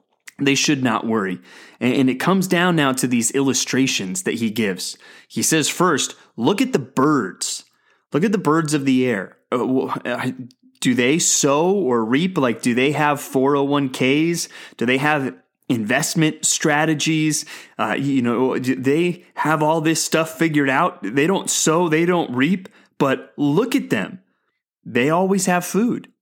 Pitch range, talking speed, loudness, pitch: 130-165 Hz, 160 wpm, -19 LUFS, 150 Hz